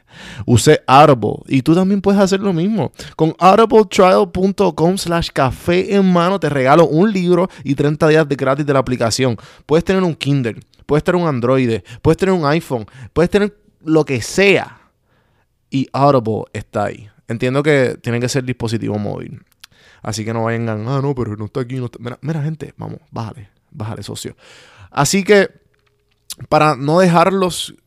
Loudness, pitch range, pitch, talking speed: -15 LUFS, 120-170 Hz, 140 Hz, 170 wpm